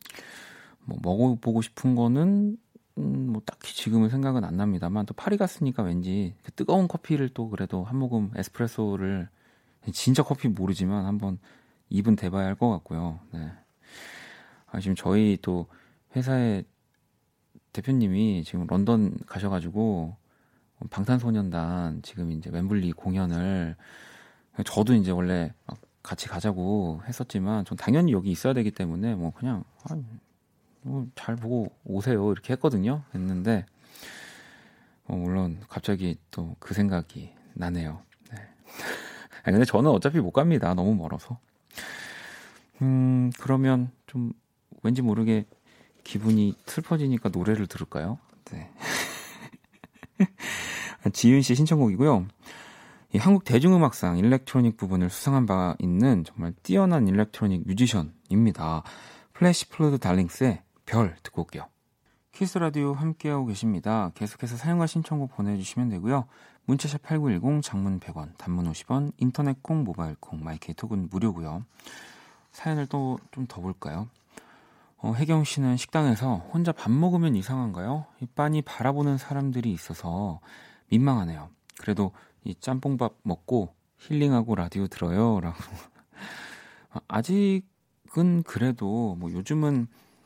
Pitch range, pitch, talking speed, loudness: 95-130 Hz, 110 Hz, 275 characters per minute, -26 LUFS